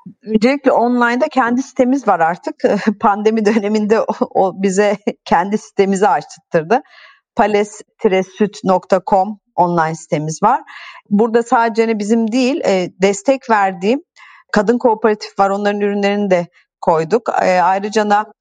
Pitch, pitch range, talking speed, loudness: 210 Hz, 195-235 Hz, 110 wpm, -15 LUFS